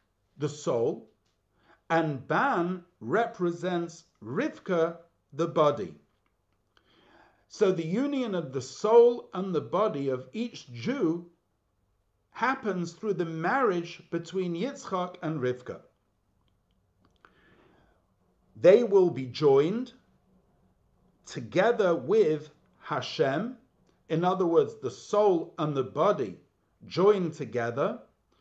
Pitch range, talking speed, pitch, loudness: 140-190 Hz, 95 wpm, 170 Hz, -28 LUFS